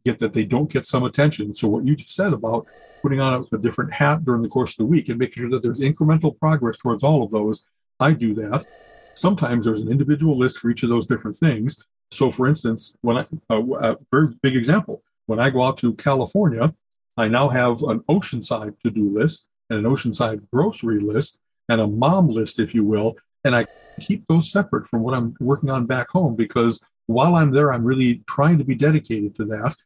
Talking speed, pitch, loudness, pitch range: 215 wpm, 130 Hz, -20 LUFS, 115-150 Hz